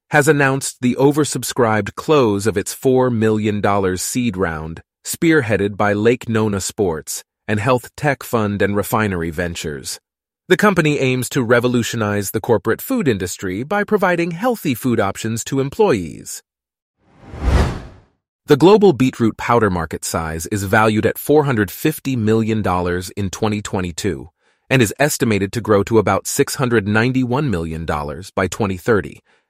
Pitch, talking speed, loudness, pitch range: 110 Hz, 130 wpm, -17 LUFS, 100-135 Hz